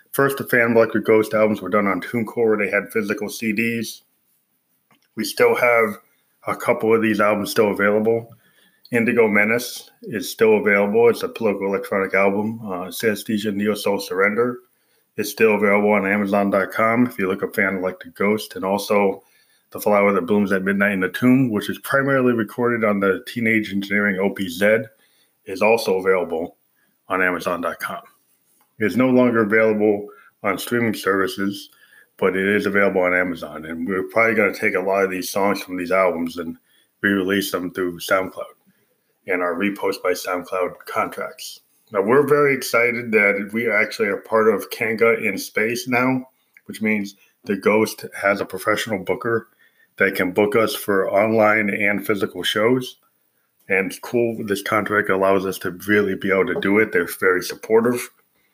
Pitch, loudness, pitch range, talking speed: 105 Hz, -20 LUFS, 95-115 Hz, 165 wpm